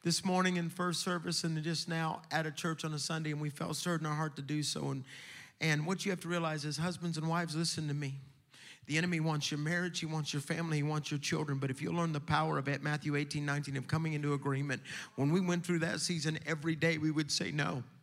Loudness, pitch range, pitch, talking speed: -35 LUFS, 150-170 Hz, 155 Hz, 255 wpm